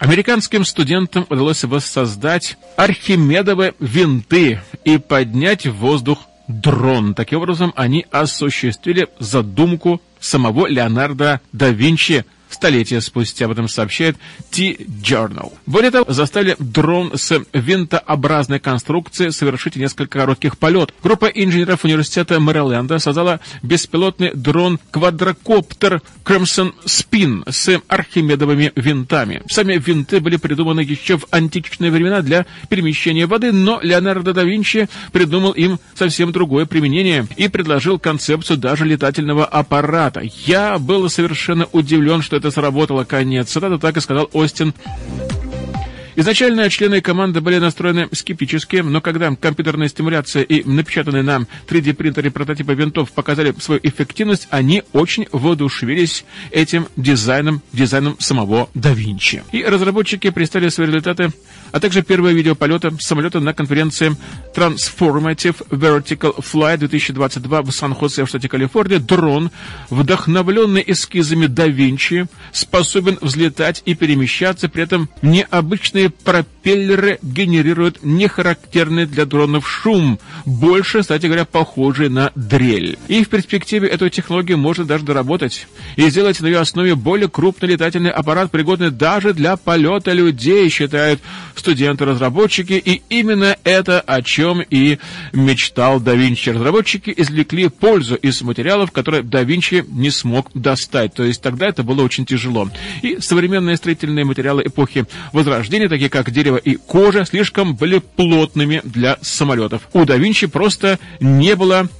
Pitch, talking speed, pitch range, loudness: 160 Hz, 125 wpm, 140-180 Hz, -15 LUFS